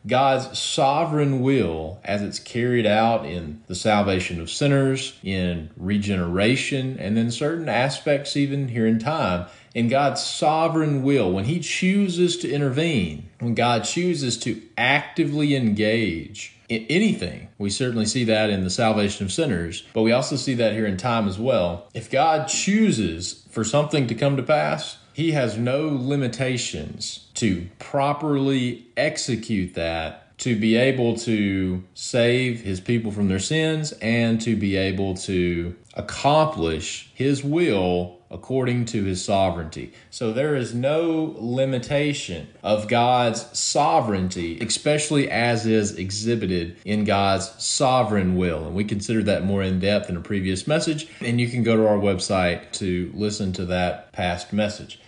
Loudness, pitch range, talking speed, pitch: -22 LUFS, 95-135 Hz, 150 wpm, 115 Hz